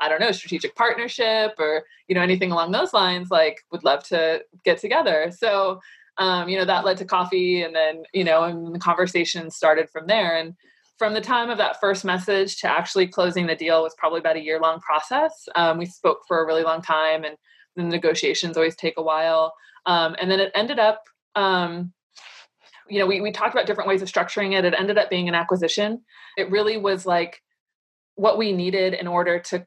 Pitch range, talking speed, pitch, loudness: 165-205 Hz, 210 wpm, 180 Hz, -22 LUFS